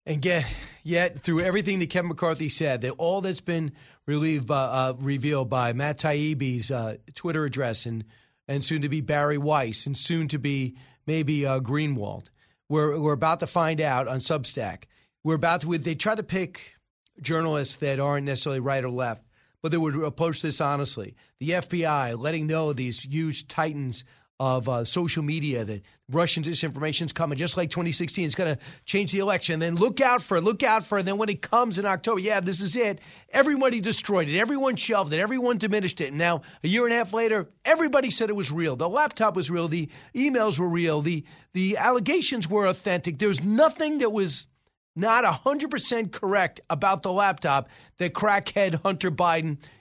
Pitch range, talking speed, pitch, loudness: 145-195 Hz, 195 wpm, 165 Hz, -26 LUFS